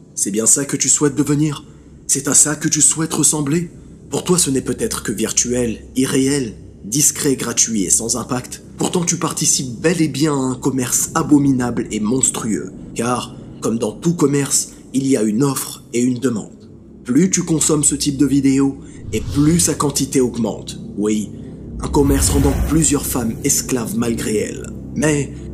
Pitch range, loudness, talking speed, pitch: 125-155 Hz, -16 LUFS, 175 wpm, 140 Hz